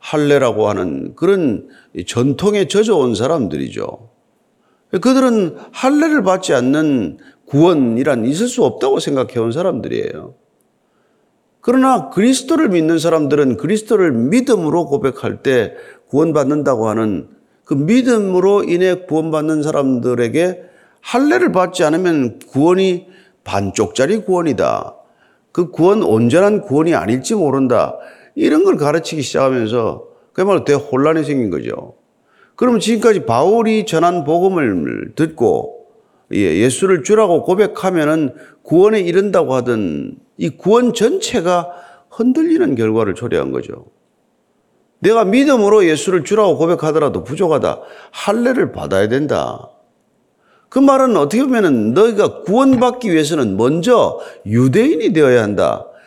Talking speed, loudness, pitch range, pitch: 290 characters per minute, -14 LUFS, 150-245 Hz, 185 Hz